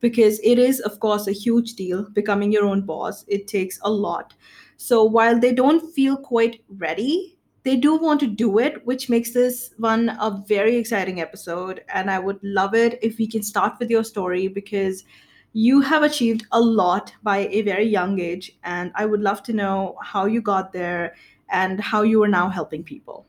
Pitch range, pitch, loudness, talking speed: 195-235 Hz, 210 Hz, -21 LUFS, 200 wpm